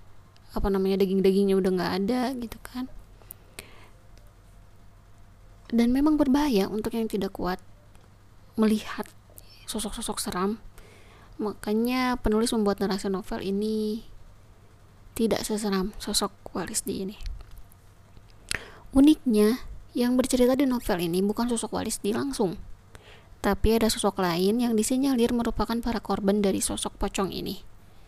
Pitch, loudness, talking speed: 200 Hz, -26 LUFS, 115 wpm